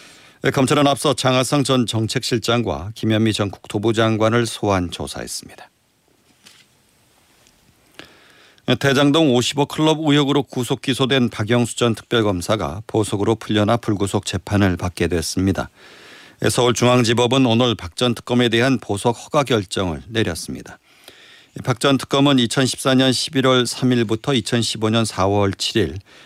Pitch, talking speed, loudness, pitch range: 115 Hz, 265 characters per minute, -18 LUFS, 105-130 Hz